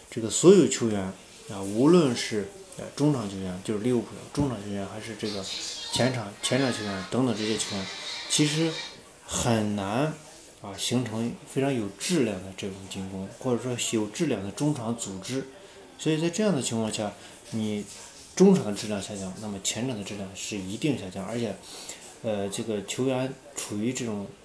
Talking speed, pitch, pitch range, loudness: 270 characters per minute, 110 Hz, 100-135 Hz, -28 LUFS